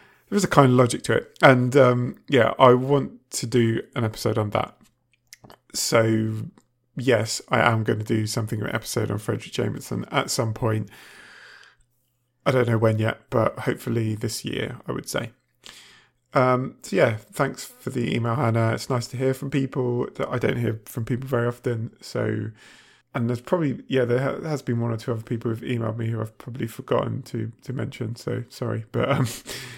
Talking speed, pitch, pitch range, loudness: 200 wpm, 120 Hz, 115-125 Hz, -24 LUFS